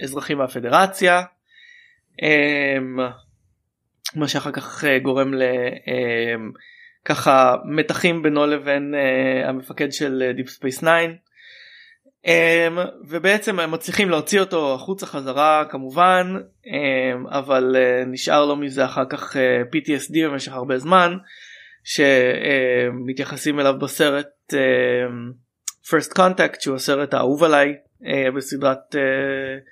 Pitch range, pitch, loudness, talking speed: 130-165 Hz, 140 Hz, -19 LUFS, 85 wpm